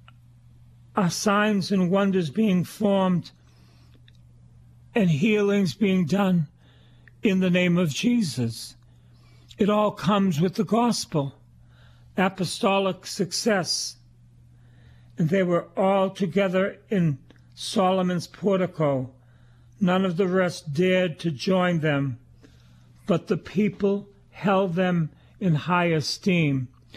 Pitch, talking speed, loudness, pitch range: 170 Hz, 105 wpm, -24 LUFS, 115-195 Hz